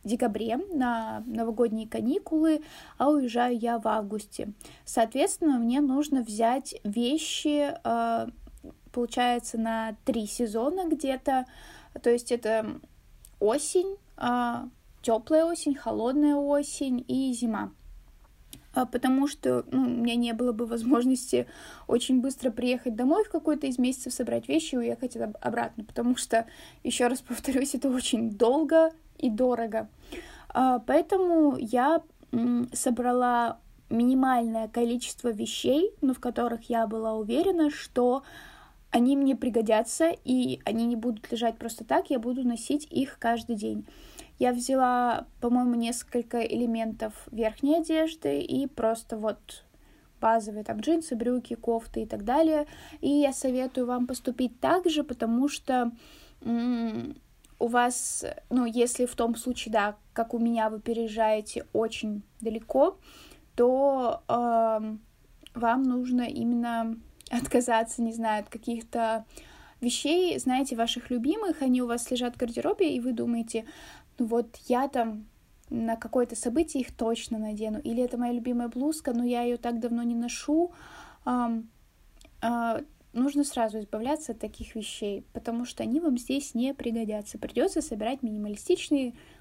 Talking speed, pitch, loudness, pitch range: 130 wpm, 245 Hz, -28 LUFS, 230-270 Hz